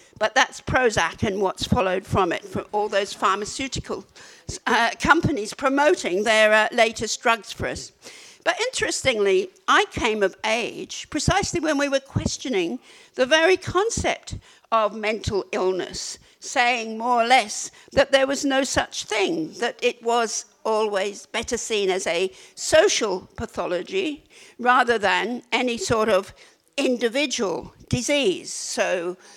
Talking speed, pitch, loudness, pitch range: 135 wpm, 245 Hz, -22 LUFS, 215-305 Hz